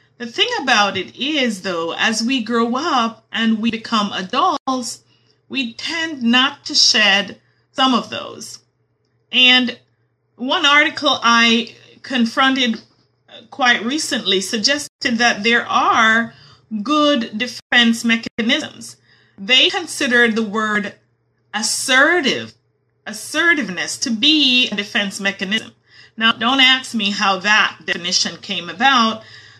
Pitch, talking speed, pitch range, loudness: 235 Hz, 115 wpm, 215-265 Hz, -15 LUFS